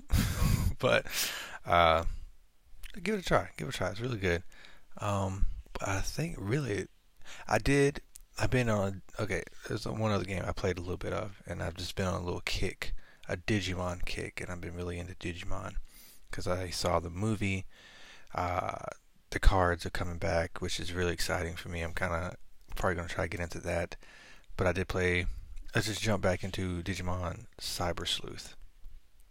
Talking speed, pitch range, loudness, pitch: 185 wpm, 85-100 Hz, -33 LUFS, 90 Hz